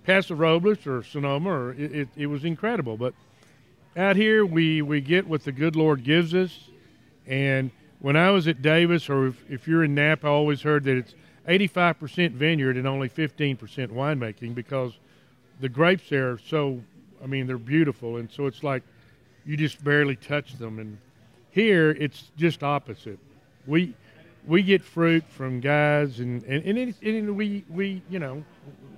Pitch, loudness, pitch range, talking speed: 145 Hz, -24 LUFS, 130-165 Hz, 175 wpm